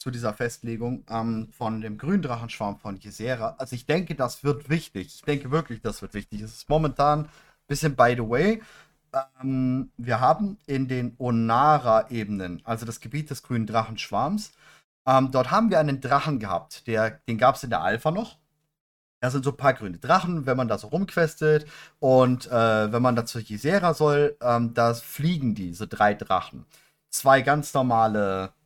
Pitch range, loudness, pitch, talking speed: 115-150 Hz, -25 LUFS, 130 Hz, 180 wpm